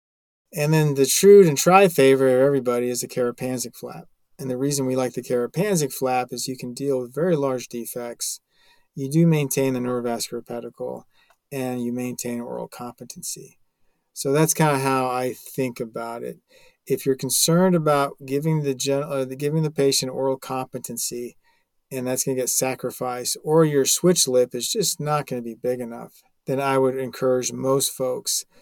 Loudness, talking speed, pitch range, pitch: -22 LUFS, 175 wpm, 125-140 Hz, 130 Hz